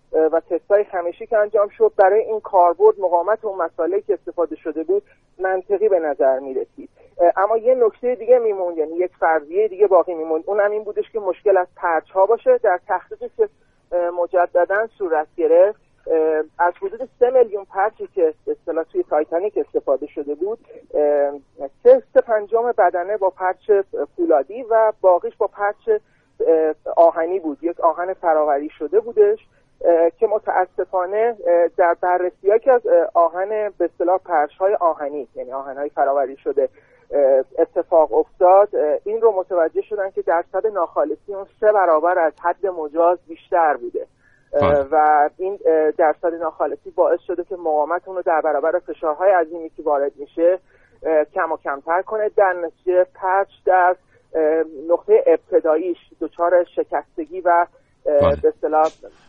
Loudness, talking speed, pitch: -19 LUFS, 140 wpm, 185 Hz